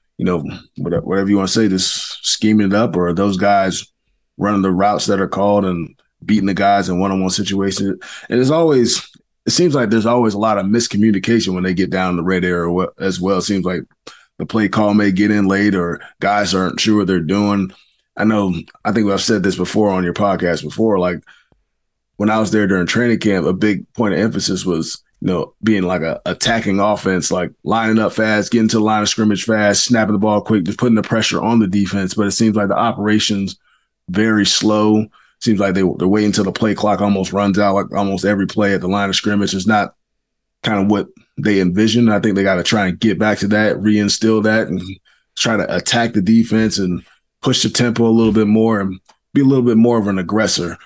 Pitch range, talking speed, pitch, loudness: 95-110 Hz, 225 wpm, 105 Hz, -16 LUFS